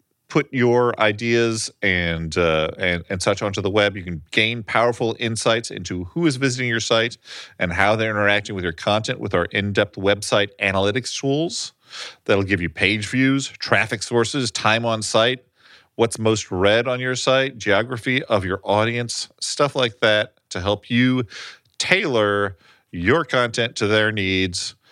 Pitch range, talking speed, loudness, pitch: 100-120 Hz, 160 wpm, -20 LUFS, 110 Hz